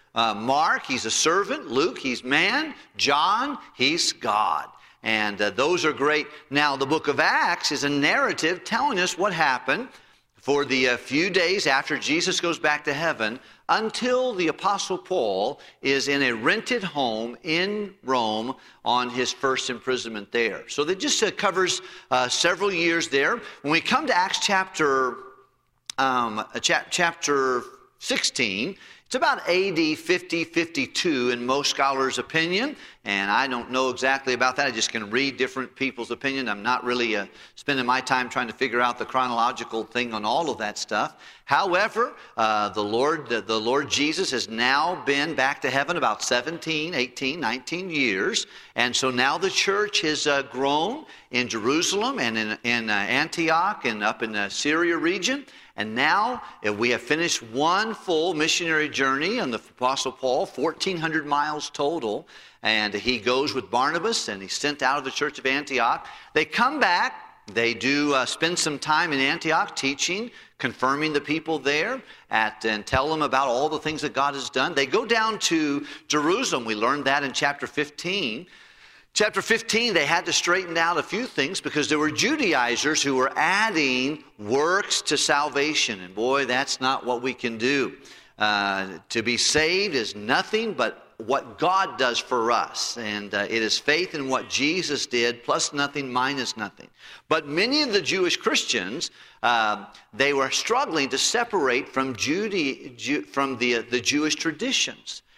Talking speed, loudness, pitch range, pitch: 170 wpm, -23 LUFS, 125-165 Hz, 140 Hz